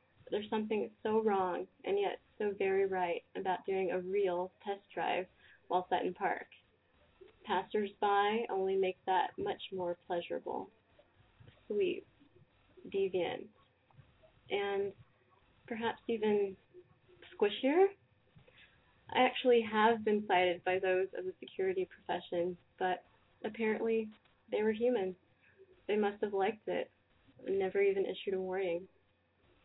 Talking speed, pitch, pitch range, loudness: 120 wpm, 210 Hz, 185-270 Hz, -35 LUFS